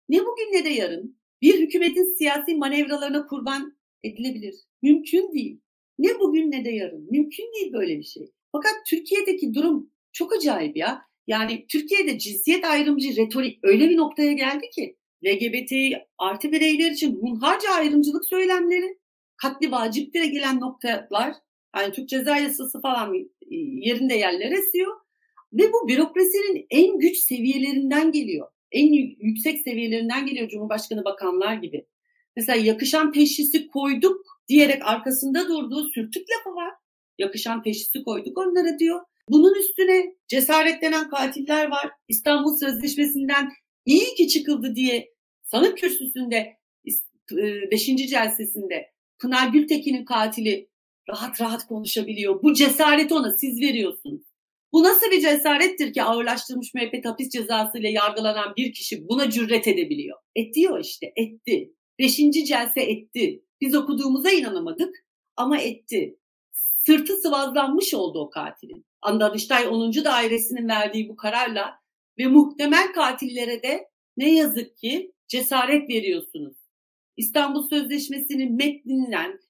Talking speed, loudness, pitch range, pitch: 125 wpm, -22 LUFS, 240-330 Hz, 285 Hz